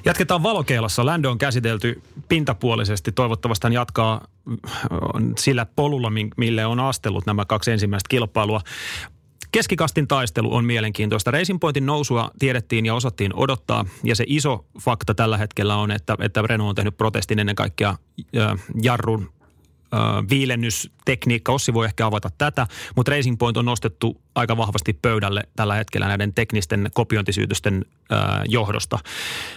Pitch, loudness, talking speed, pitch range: 115 Hz, -21 LUFS, 130 wpm, 105-125 Hz